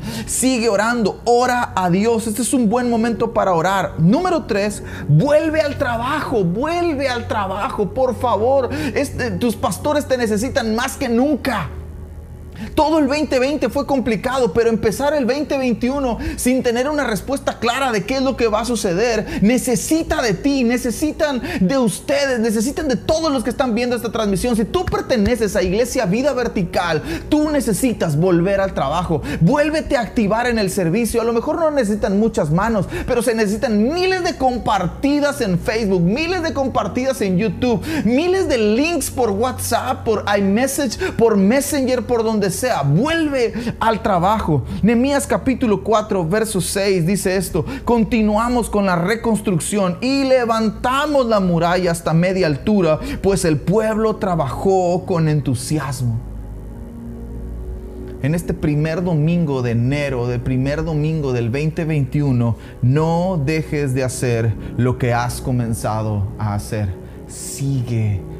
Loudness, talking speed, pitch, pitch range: -18 LUFS, 145 wpm, 220 Hz, 165-255 Hz